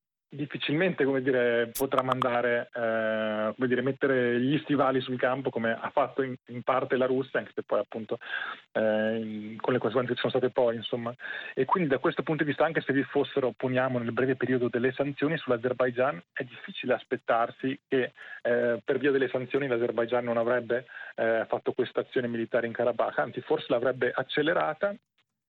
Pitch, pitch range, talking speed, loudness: 125 Hz, 120-135 Hz, 180 wpm, -28 LUFS